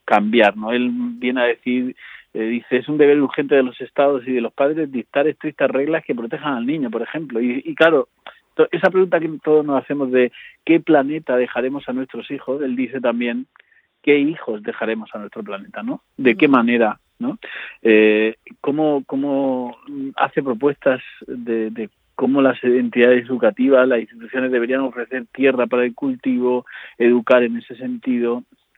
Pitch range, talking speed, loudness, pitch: 120-145 Hz, 170 wpm, -19 LUFS, 130 Hz